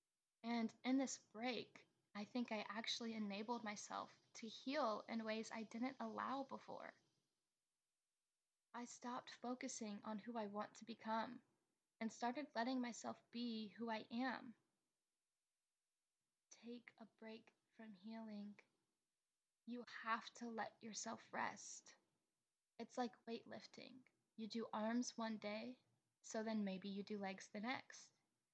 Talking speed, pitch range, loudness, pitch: 130 wpm, 215-240 Hz, -49 LUFS, 225 Hz